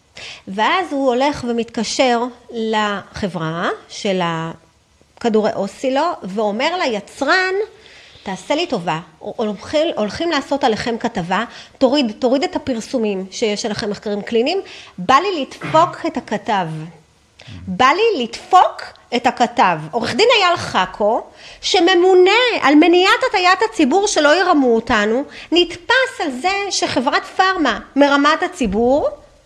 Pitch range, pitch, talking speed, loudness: 215-345 Hz, 260 Hz, 115 wpm, -16 LUFS